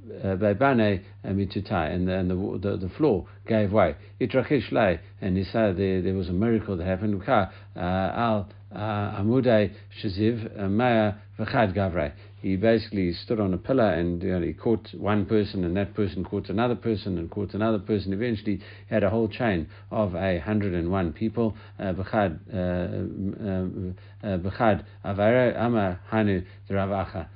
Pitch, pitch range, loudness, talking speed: 100 Hz, 95-110 Hz, -26 LUFS, 130 wpm